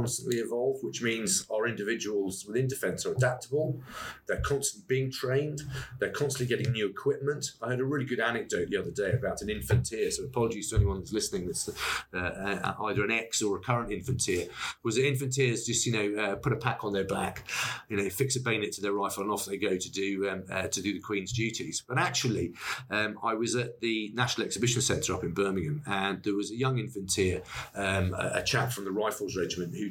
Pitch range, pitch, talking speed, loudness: 100-130 Hz, 115 Hz, 225 wpm, -31 LUFS